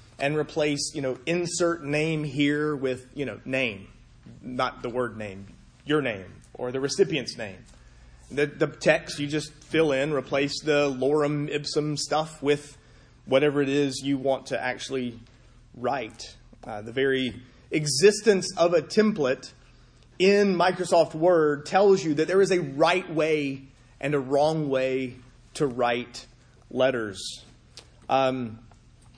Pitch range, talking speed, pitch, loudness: 125-155 Hz, 140 wpm, 140 Hz, -25 LUFS